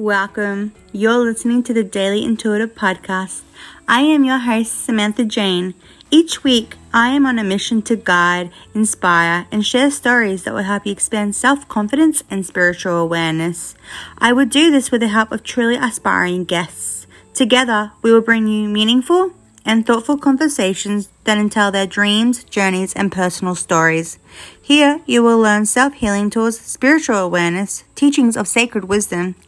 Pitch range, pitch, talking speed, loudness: 195-245 Hz, 215 Hz, 155 wpm, -15 LUFS